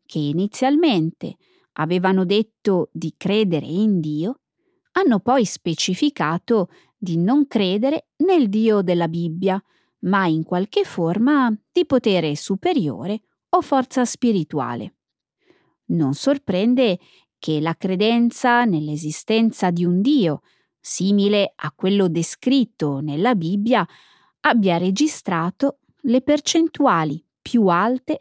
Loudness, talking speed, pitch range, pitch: -20 LUFS, 105 wpm, 170-255 Hz, 205 Hz